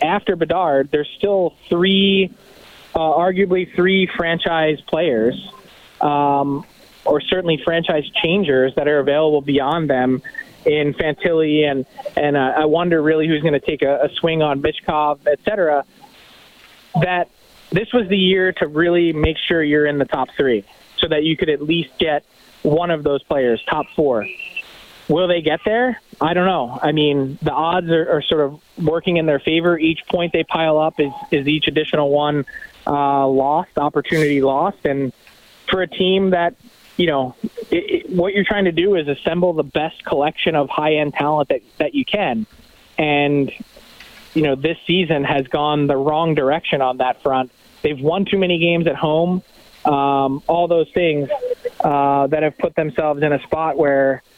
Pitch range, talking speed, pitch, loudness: 145-180 Hz, 175 wpm, 160 Hz, -18 LUFS